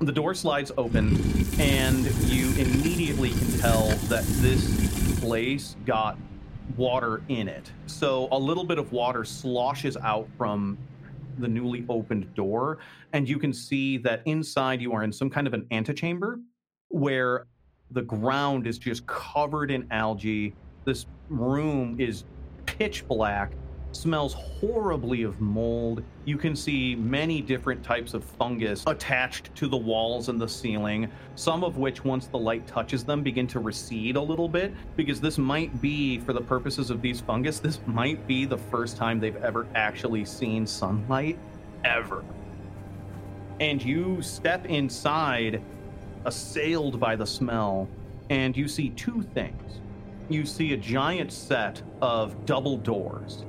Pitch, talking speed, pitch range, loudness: 125 Hz, 150 wpm, 110-140 Hz, -28 LUFS